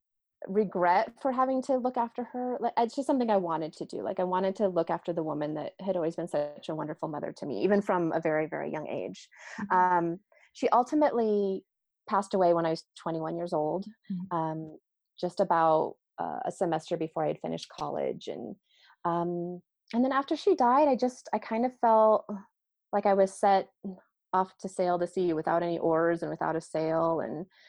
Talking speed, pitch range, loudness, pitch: 195 wpm, 165-215 Hz, -29 LUFS, 185 Hz